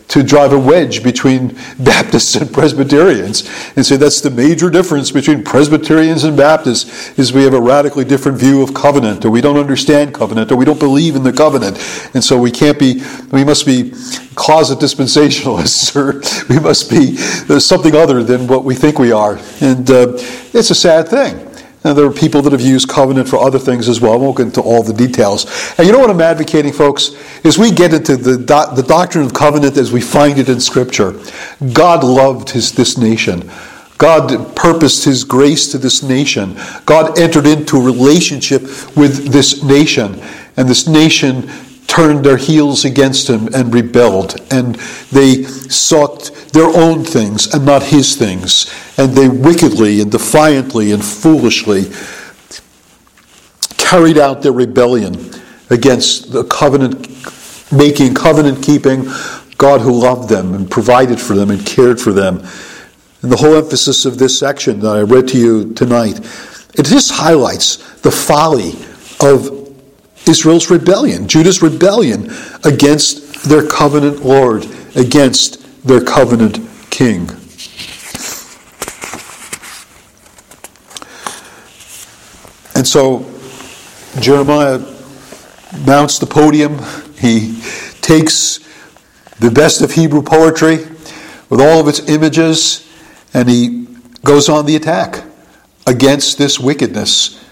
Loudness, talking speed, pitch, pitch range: -10 LUFS, 145 wpm, 140 Hz, 125-150 Hz